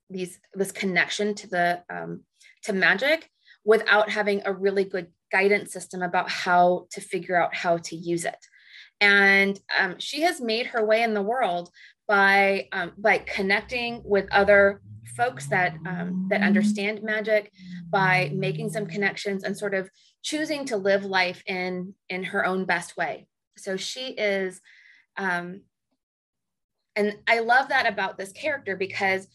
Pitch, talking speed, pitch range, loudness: 195 Hz, 155 wpm, 185-210 Hz, -24 LUFS